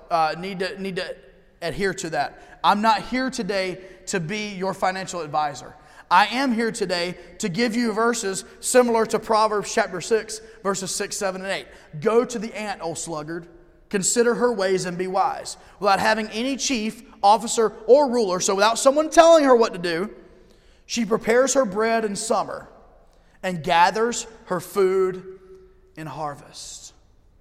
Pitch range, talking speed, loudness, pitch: 185-225 Hz, 160 wpm, -22 LUFS, 200 Hz